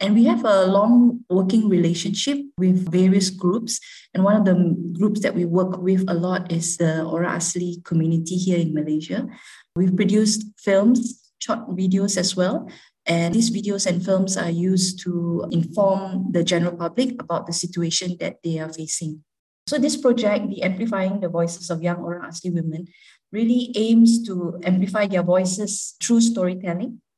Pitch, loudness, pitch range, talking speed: 185 Hz, -21 LUFS, 175-215 Hz, 165 wpm